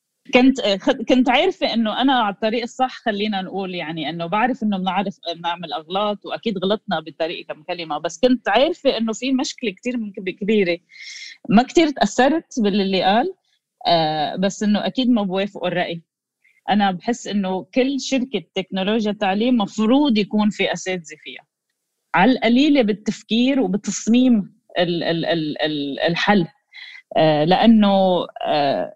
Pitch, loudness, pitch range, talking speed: 210 Hz, -19 LUFS, 185-250 Hz, 120 wpm